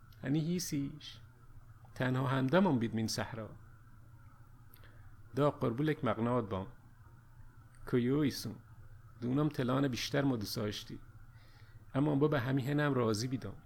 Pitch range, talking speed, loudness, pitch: 110-135 Hz, 110 wpm, -34 LUFS, 115 Hz